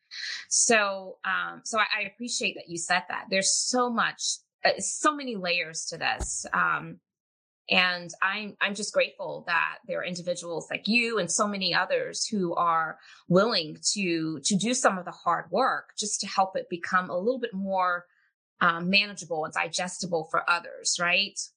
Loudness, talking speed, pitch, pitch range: -27 LUFS, 165 wpm, 190 Hz, 175-215 Hz